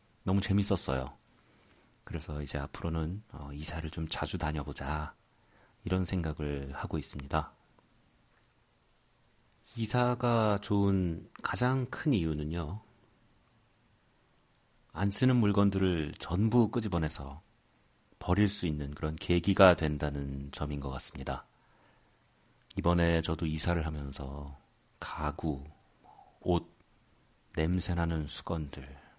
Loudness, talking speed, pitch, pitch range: -32 LUFS, 215 characters per minute, 85 Hz, 75-105 Hz